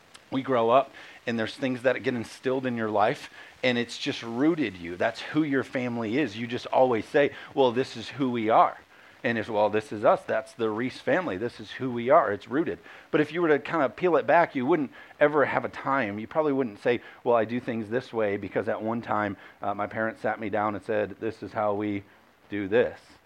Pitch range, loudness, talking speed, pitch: 110-130 Hz, -27 LUFS, 240 wpm, 115 Hz